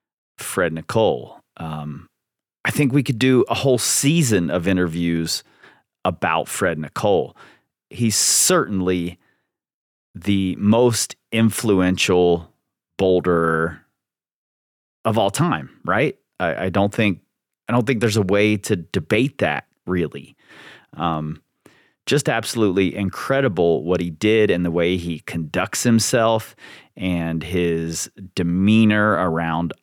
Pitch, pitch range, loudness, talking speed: 95 Hz, 85-110 Hz, -20 LUFS, 115 wpm